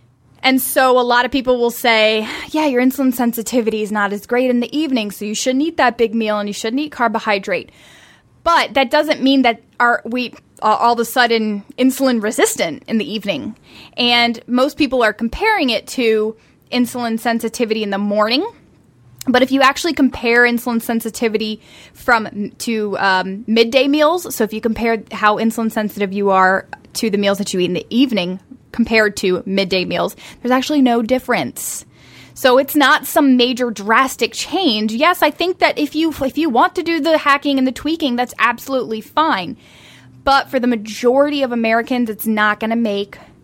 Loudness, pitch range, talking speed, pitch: -16 LUFS, 220-270 Hz, 185 wpm, 240 Hz